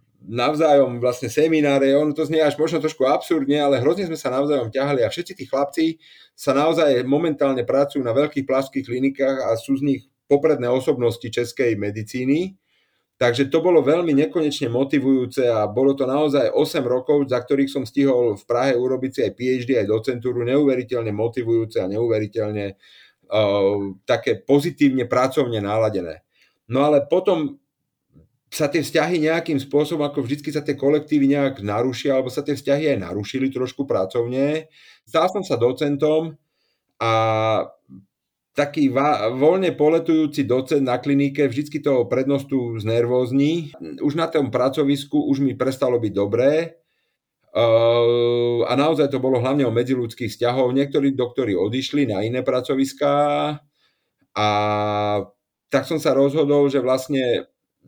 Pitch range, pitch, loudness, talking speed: 120-145 Hz, 135 Hz, -20 LUFS, 140 wpm